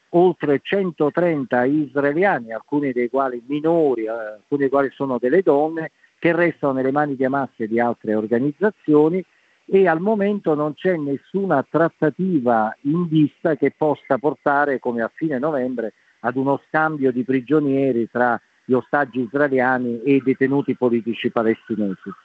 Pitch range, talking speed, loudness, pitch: 125-155 Hz, 140 wpm, -20 LUFS, 140 Hz